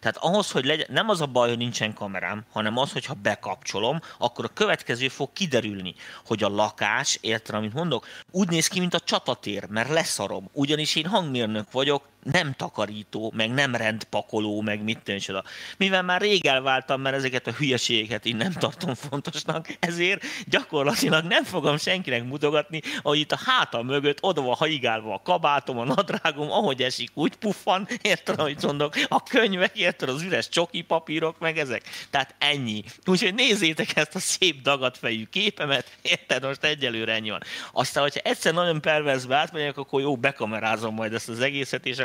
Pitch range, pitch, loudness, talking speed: 115-170 Hz, 140 Hz, -25 LUFS, 170 wpm